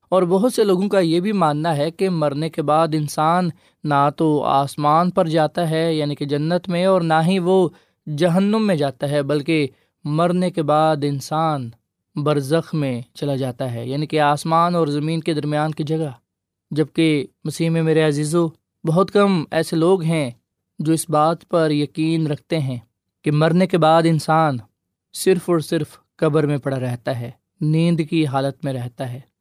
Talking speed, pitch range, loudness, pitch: 180 wpm, 145-170 Hz, -19 LUFS, 155 Hz